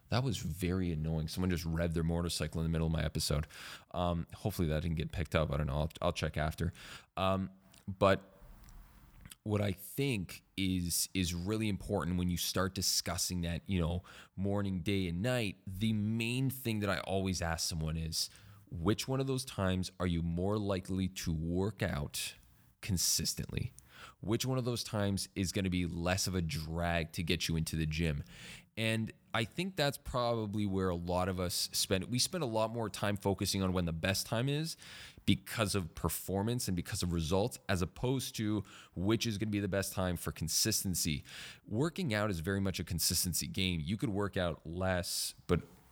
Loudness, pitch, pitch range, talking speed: -35 LUFS, 95 Hz, 85-105 Hz, 195 wpm